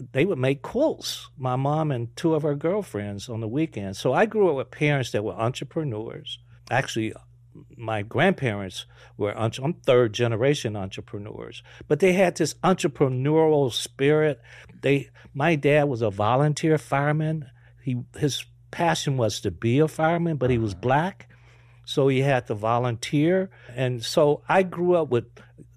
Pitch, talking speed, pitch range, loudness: 130 Hz, 155 wpm, 115-155 Hz, -24 LUFS